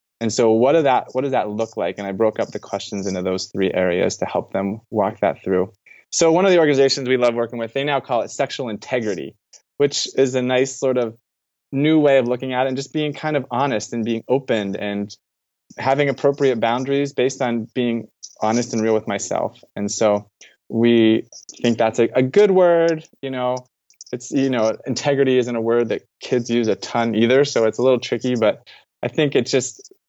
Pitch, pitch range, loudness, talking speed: 120 Hz, 110-135 Hz, -20 LUFS, 215 wpm